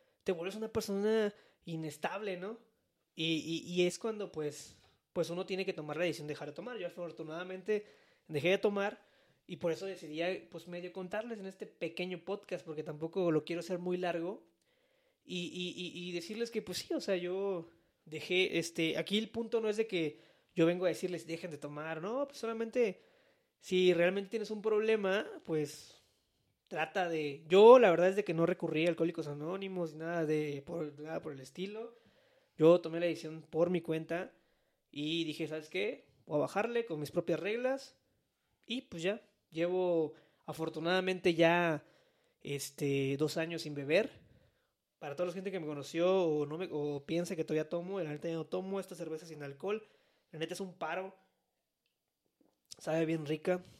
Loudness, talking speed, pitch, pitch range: -35 LUFS, 180 wpm, 175 Hz, 160-195 Hz